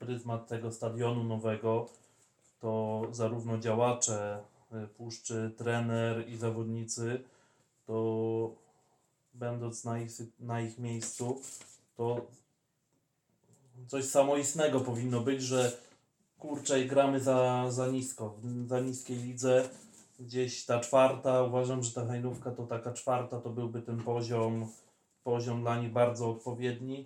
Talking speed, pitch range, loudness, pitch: 115 wpm, 115-130 Hz, -33 LUFS, 120 Hz